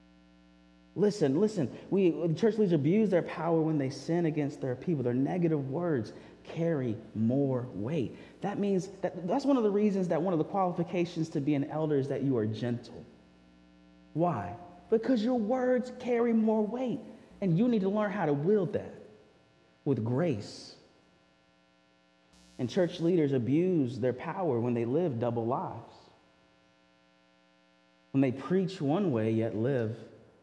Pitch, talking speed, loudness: 145 Hz, 155 wpm, -30 LUFS